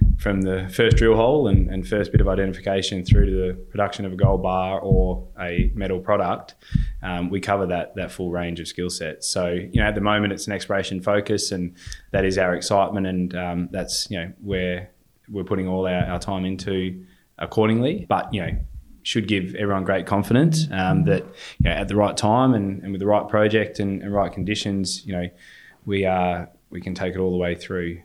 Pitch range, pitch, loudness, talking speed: 90-100 Hz, 95 Hz, -23 LUFS, 215 wpm